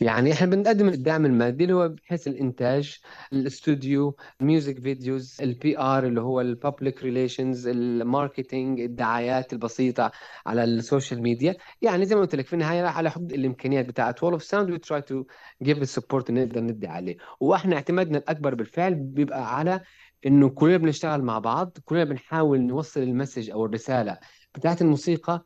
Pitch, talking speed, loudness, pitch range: 135 Hz, 150 wpm, -25 LUFS, 125-160 Hz